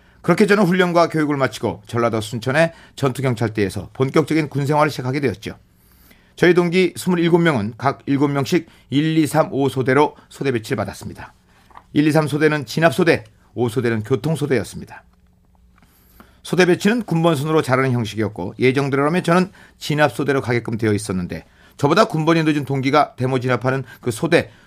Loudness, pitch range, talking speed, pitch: -19 LUFS, 120-160 Hz, 345 characters per minute, 140 Hz